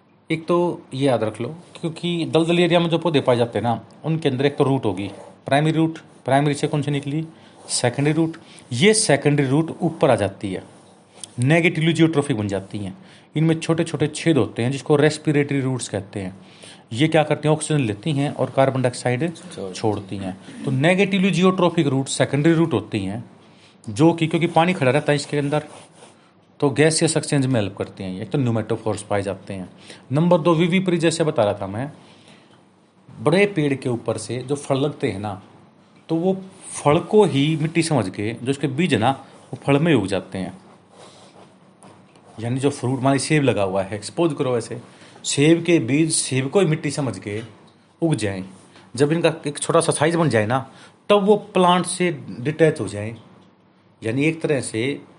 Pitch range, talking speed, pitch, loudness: 115-165 Hz, 190 wpm, 145 Hz, -20 LUFS